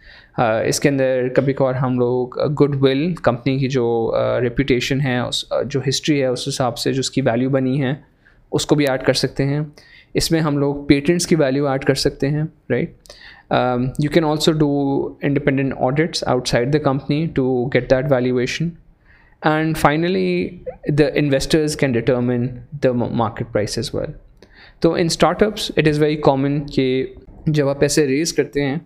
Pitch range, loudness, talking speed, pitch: 130-155 Hz, -19 LUFS, 180 wpm, 140 Hz